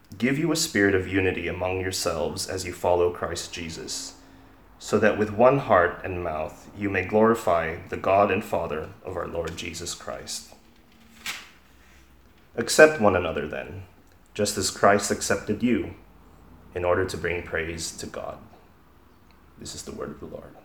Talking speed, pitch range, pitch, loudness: 160 wpm, 85-105 Hz, 95 Hz, -25 LUFS